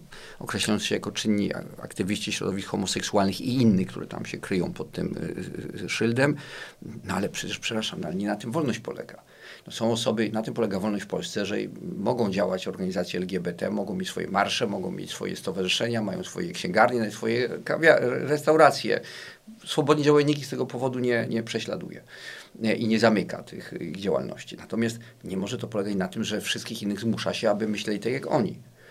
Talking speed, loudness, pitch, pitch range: 180 wpm, -27 LUFS, 110 Hz, 105-125 Hz